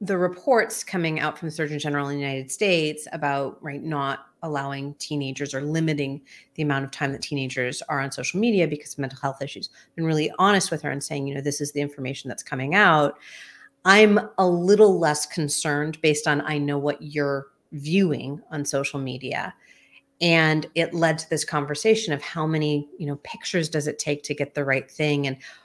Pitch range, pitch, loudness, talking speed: 140-165 Hz, 150 Hz, -24 LUFS, 200 wpm